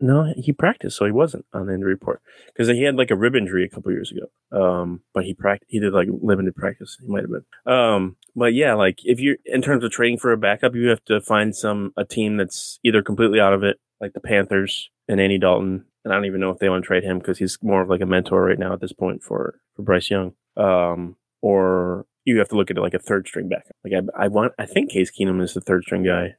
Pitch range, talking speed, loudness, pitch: 95-110 Hz, 270 wpm, -21 LUFS, 100 Hz